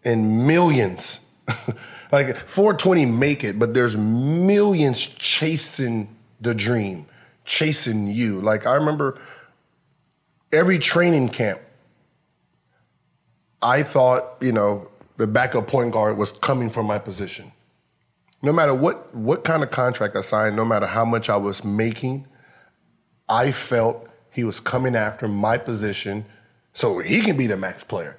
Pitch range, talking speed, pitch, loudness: 110-140 Hz, 135 wpm, 120 Hz, -21 LUFS